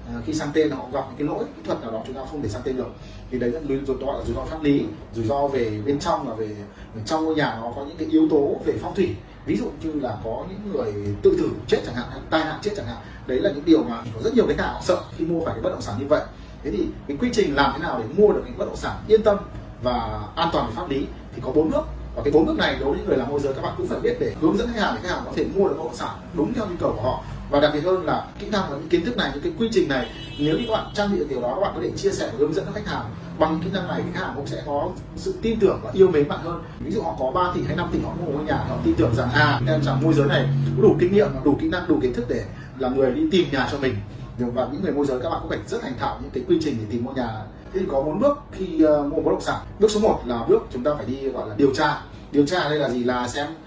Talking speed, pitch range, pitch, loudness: 335 wpm, 125-170 Hz, 145 Hz, -23 LUFS